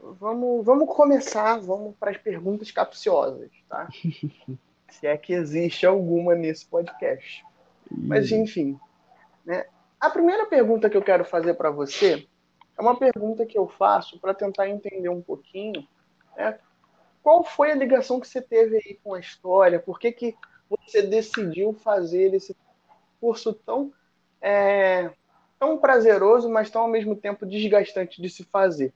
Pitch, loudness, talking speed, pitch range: 210 Hz, -23 LUFS, 150 wpm, 185-245 Hz